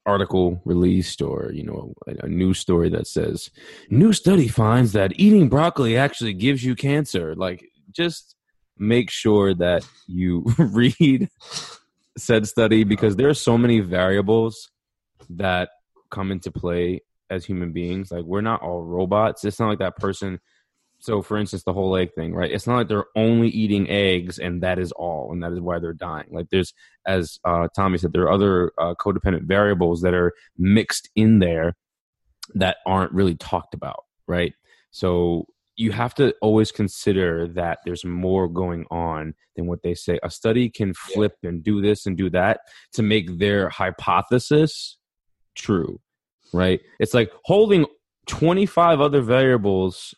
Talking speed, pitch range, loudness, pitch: 165 wpm, 90-115 Hz, -21 LUFS, 95 Hz